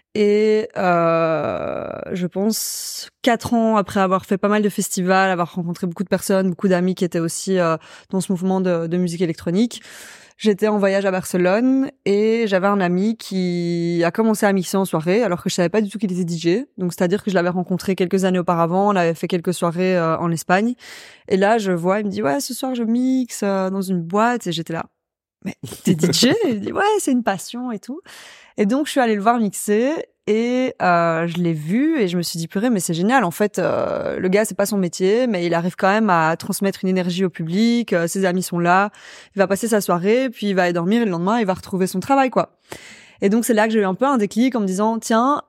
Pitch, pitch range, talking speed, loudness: 195 Hz, 180-225 Hz, 245 wpm, -19 LUFS